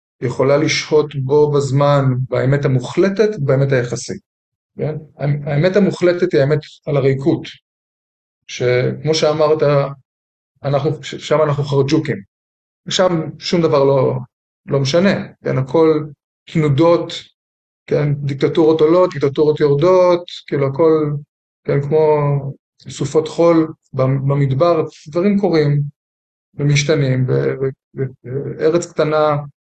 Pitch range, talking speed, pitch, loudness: 135-155 Hz, 95 wpm, 145 Hz, -16 LUFS